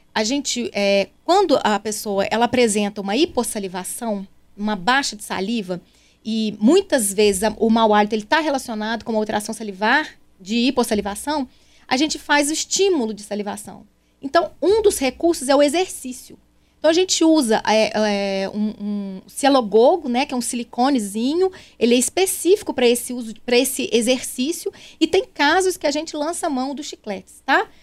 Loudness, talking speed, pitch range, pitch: -19 LUFS, 170 wpm, 215-305 Hz, 245 Hz